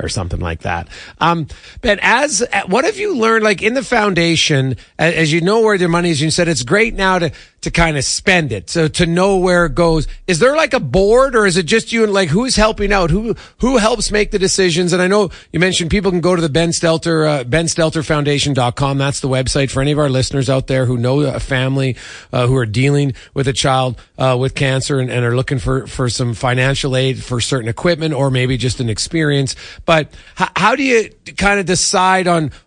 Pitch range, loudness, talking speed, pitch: 130-190 Hz, -15 LUFS, 230 wpm, 160 Hz